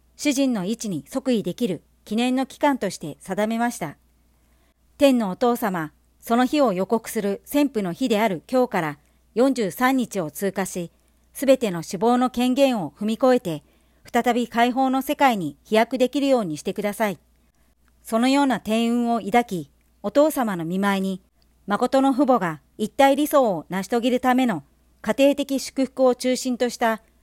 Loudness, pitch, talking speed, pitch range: -22 LUFS, 230 Hz, 300 characters per minute, 190-255 Hz